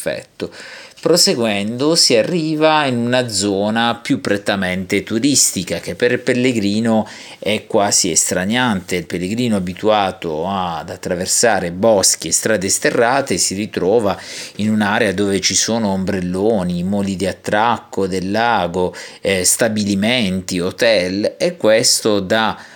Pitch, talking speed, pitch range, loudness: 105 Hz, 120 wpm, 95-120 Hz, -16 LUFS